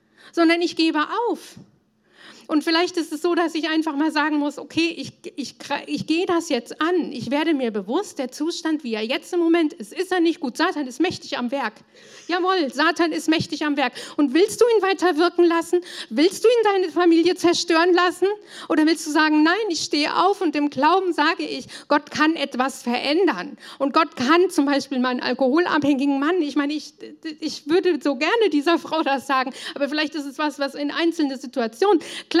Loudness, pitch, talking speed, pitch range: -21 LUFS, 315 Hz, 200 wpm, 285-345 Hz